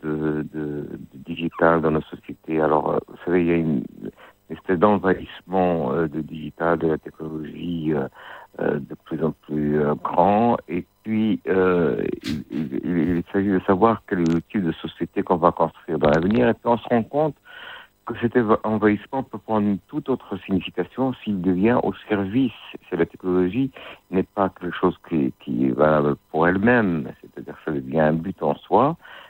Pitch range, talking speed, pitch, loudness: 80-105 Hz, 180 wpm, 90 Hz, -22 LUFS